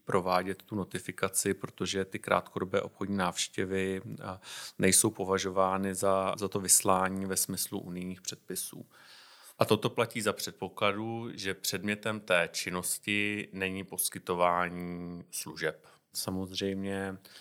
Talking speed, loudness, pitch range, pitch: 105 wpm, -31 LUFS, 95-100 Hz, 95 Hz